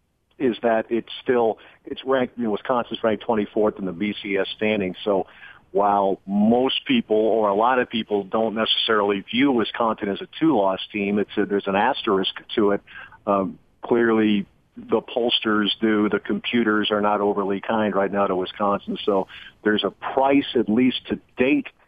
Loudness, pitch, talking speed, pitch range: -22 LUFS, 105 Hz, 175 wpm, 100-115 Hz